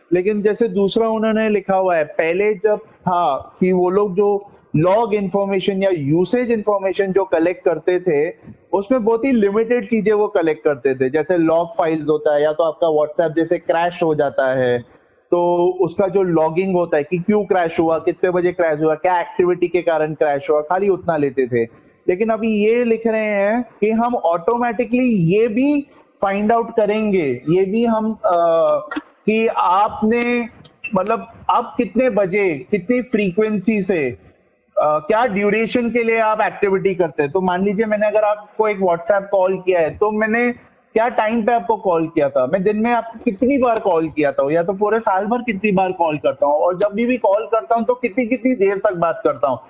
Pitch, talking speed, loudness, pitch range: 200 Hz, 195 wpm, -18 LUFS, 170-225 Hz